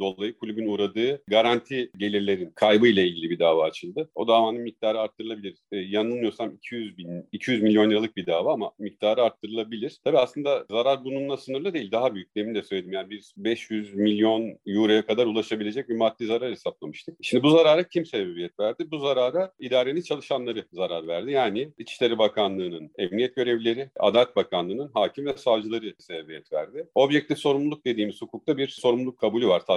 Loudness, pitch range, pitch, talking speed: -25 LUFS, 105-130 Hz, 115 Hz, 165 wpm